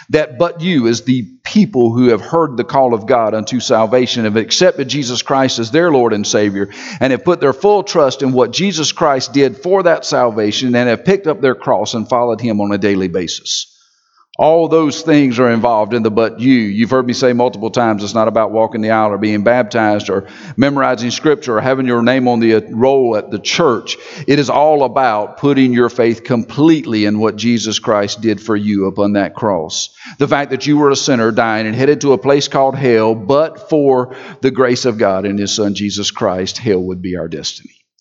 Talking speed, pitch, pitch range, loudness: 215 wpm, 120 Hz, 110-140 Hz, -13 LUFS